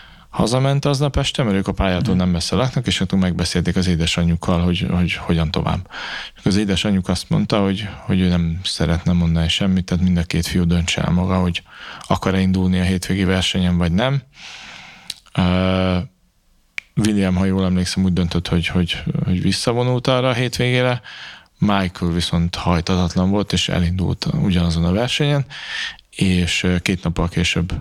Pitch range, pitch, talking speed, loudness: 85-95 Hz, 90 Hz, 155 wpm, -19 LUFS